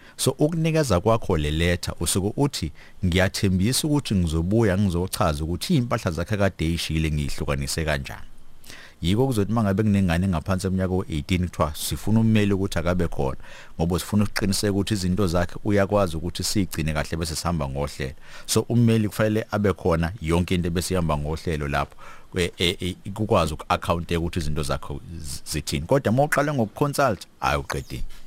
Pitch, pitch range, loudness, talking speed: 90 Hz, 80-105 Hz, -24 LUFS, 140 wpm